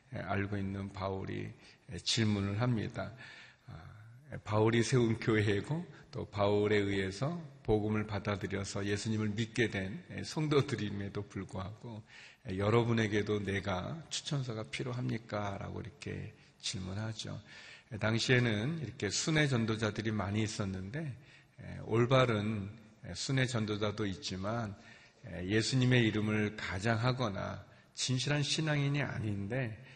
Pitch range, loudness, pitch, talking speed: 100-125 Hz, -34 LUFS, 110 Hz, 265 characters per minute